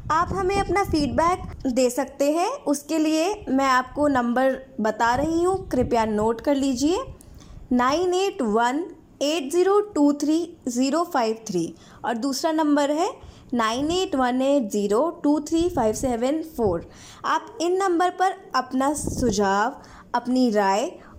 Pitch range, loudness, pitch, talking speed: 250-330 Hz, -23 LUFS, 280 Hz, 140 wpm